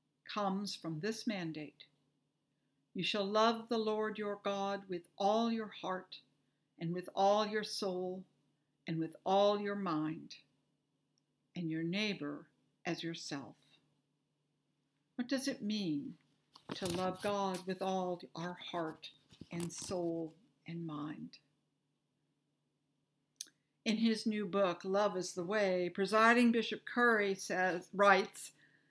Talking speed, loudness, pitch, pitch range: 120 wpm, -36 LUFS, 180 Hz, 150-205 Hz